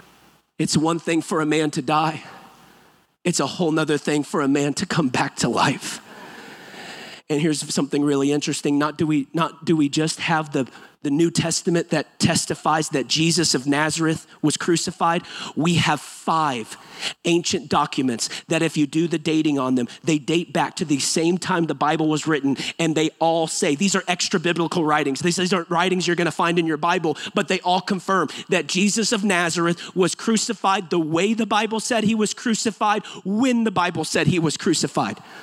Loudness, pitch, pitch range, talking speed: -21 LUFS, 165 Hz, 155-180 Hz, 195 wpm